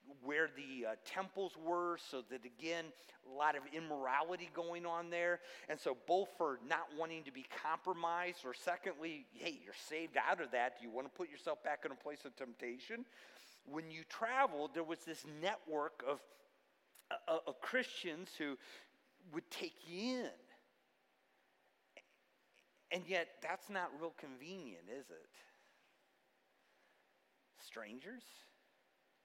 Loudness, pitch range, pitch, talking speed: -43 LUFS, 150-180 Hz, 165 Hz, 140 wpm